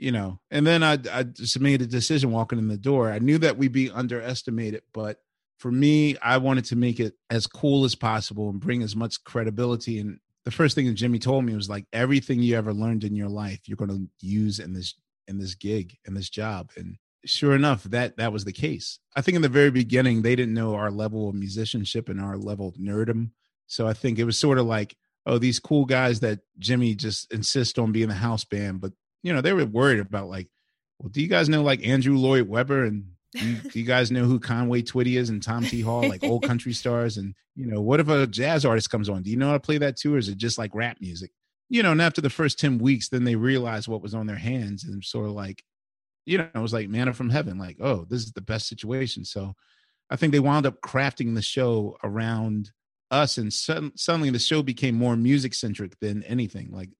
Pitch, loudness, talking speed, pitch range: 120 Hz, -25 LUFS, 240 wpm, 105-130 Hz